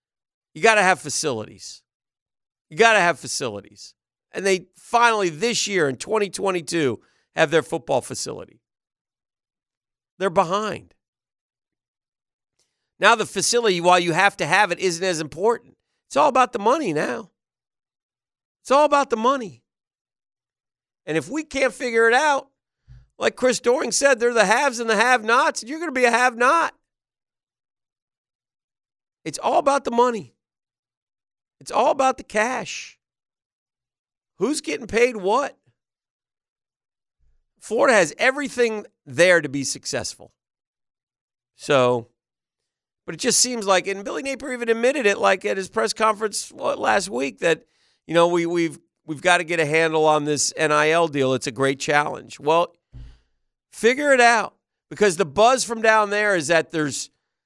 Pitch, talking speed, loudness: 180 Hz, 145 wpm, -20 LUFS